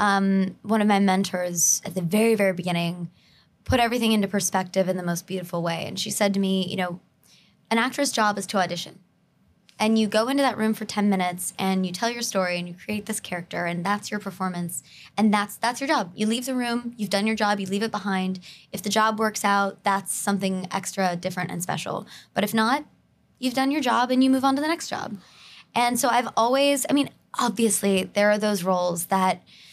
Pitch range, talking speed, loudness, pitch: 185-225 Hz, 220 wpm, -24 LUFS, 200 Hz